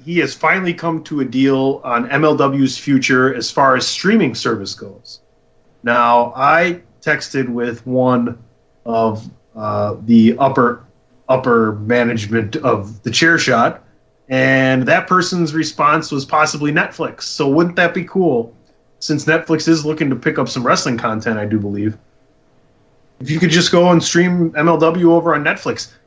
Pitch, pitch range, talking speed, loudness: 135 Hz, 120-165 Hz, 155 wpm, -15 LUFS